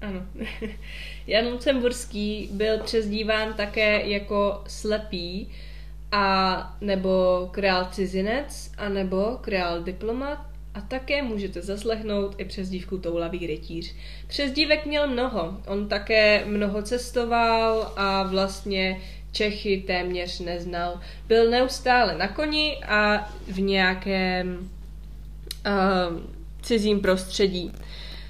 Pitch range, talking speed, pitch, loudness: 185-220 Hz, 95 wpm, 200 Hz, -25 LUFS